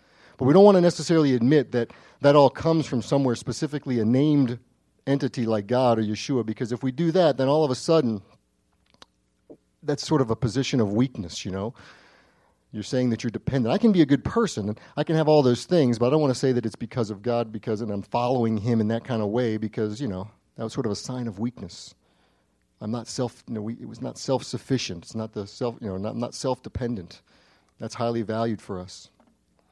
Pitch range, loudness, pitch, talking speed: 110-135 Hz, -24 LUFS, 120 Hz, 230 wpm